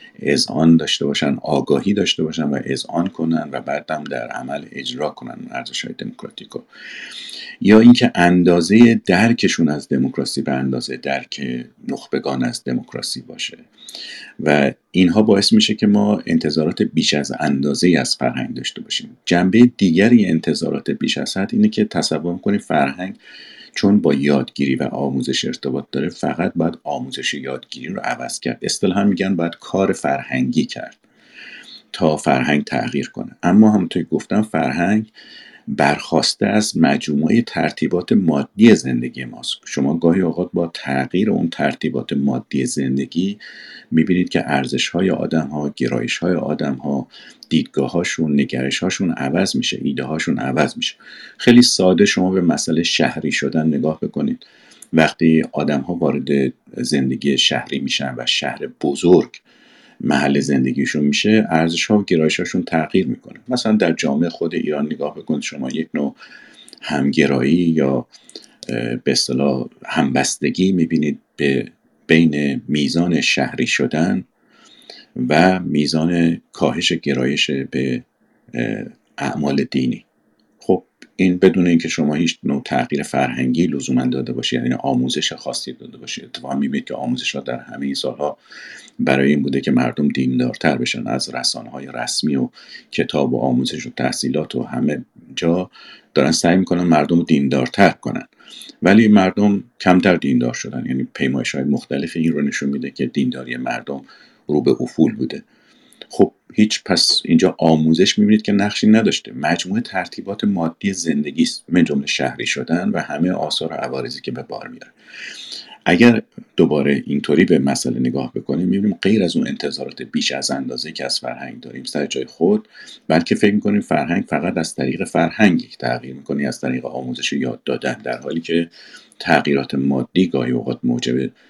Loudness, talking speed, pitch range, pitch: -18 LUFS, 145 wpm, 70-90 Hz, 80 Hz